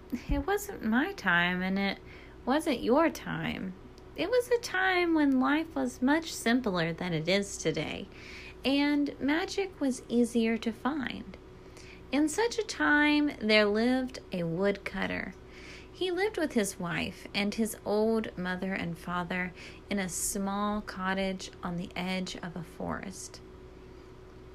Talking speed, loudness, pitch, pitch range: 140 wpm, -30 LUFS, 230 Hz, 190-295 Hz